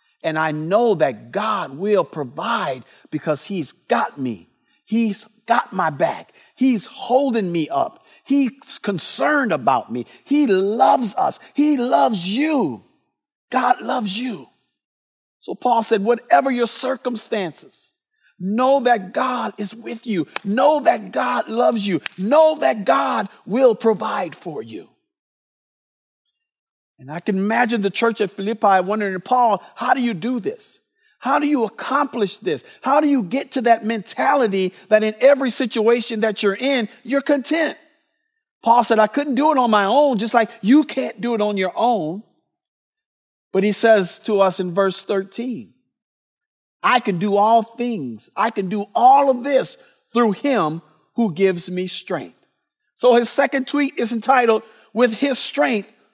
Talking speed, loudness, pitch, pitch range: 155 wpm, -19 LUFS, 230 Hz, 200-270 Hz